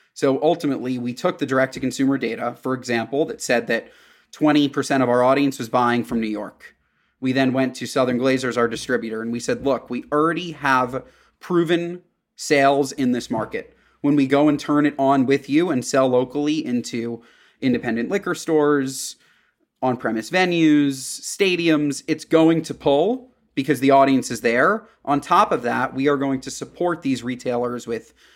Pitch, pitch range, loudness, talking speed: 135 Hz, 125-150 Hz, -21 LUFS, 180 wpm